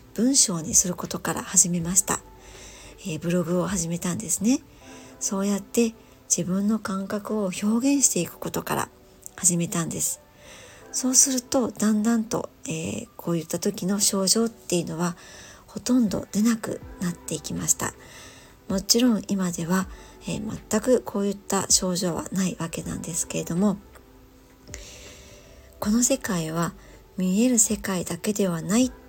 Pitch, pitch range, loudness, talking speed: 195 Hz, 180-225 Hz, -24 LUFS, 295 characters per minute